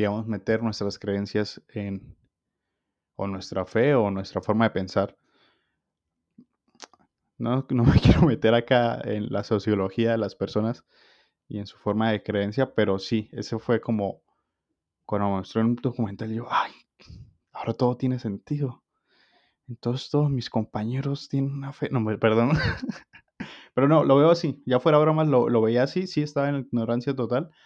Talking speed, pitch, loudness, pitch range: 160 wpm, 115 Hz, -25 LUFS, 105-130 Hz